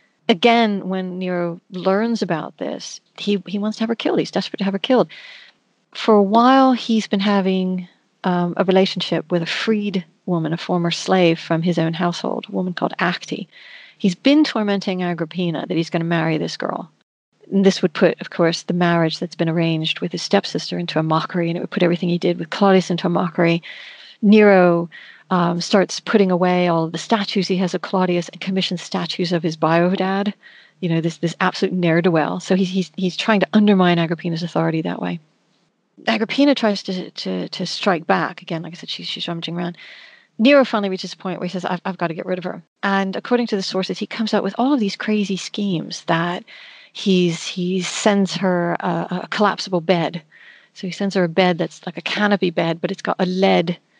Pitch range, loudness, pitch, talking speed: 175-200 Hz, -19 LUFS, 185 Hz, 210 wpm